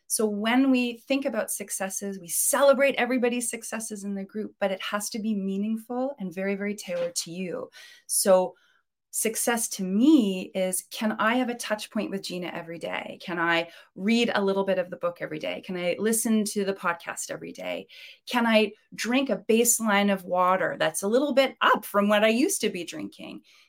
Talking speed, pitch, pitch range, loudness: 200 wpm, 210 Hz, 190-240 Hz, -26 LUFS